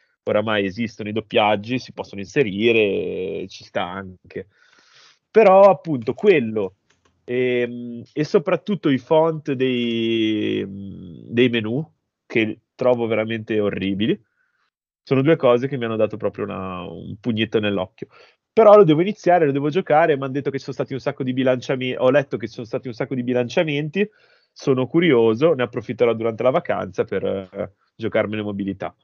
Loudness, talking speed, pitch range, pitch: -20 LUFS, 155 wpm, 110-145 Hz, 125 Hz